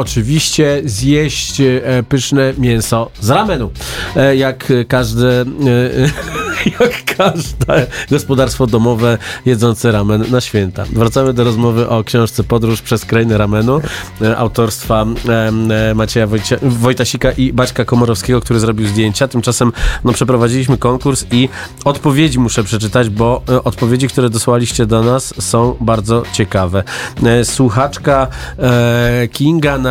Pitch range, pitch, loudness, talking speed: 115-130 Hz, 120 Hz, -13 LUFS, 110 wpm